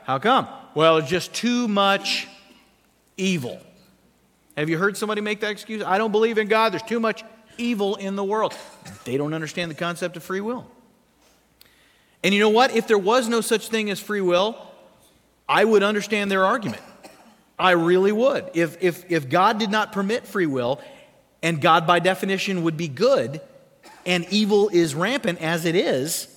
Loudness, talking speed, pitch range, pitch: -21 LUFS, 180 wpm, 175-220 Hz, 200 Hz